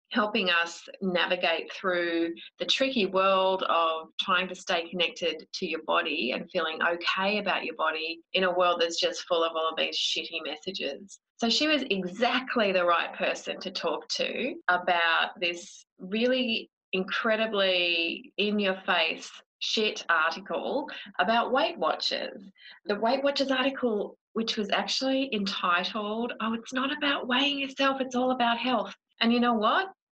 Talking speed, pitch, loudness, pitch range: 155 wpm, 200 Hz, -27 LUFS, 180-245 Hz